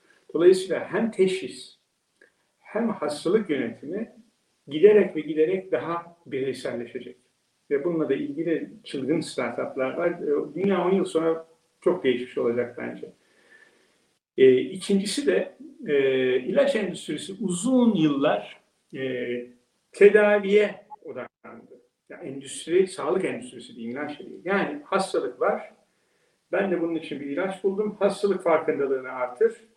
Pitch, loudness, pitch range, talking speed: 195 Hz, -25 LUFS, 155-240 Hz, 115 wpm